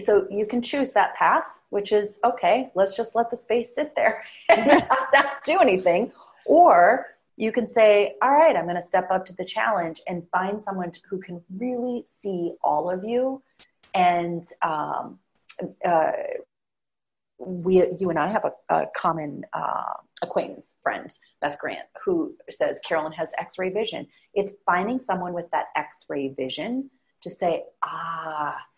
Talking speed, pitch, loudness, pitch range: 160 wpm, 195 Hz, -24 LUFS, 175-240 Hz